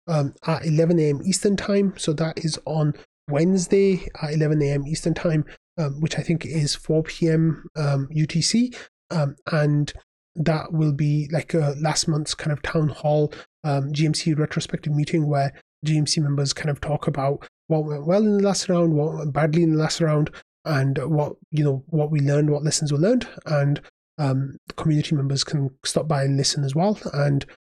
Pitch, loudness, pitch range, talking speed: 155 Hz, -23 LUFS, 145-165 Hz, 190 wpm